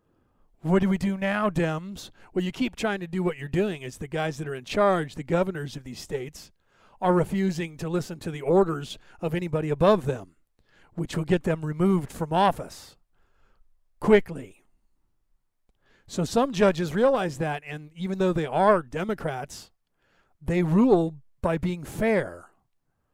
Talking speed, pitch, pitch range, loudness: 160 wpm, 175 Hz, 155-190 Hz, -26 LUFS